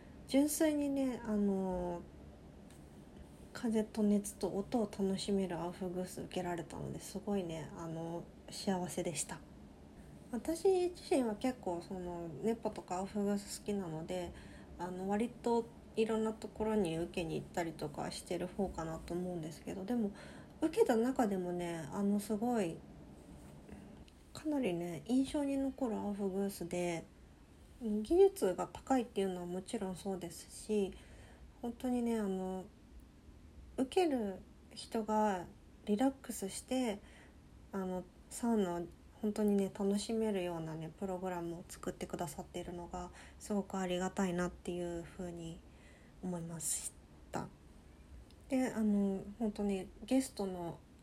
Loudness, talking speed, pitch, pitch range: -38 LUFS, 275 characters per minute, 195 Hz, 175-220 Hz